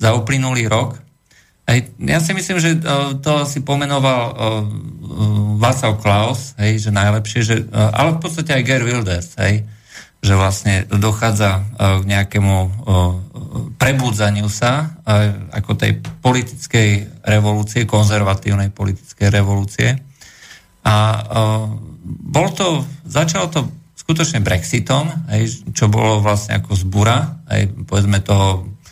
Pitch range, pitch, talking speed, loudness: 105-135 Hz, 110 Hz, 100 wpm, -16 LUFS